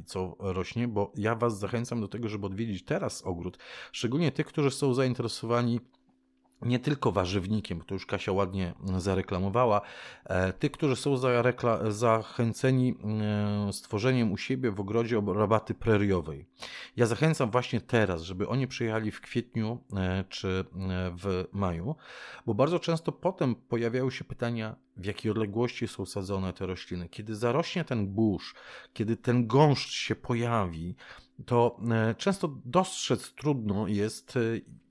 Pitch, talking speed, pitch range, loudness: 115 Hz, 130 wpm, 100-125 Hz, -30 LUFS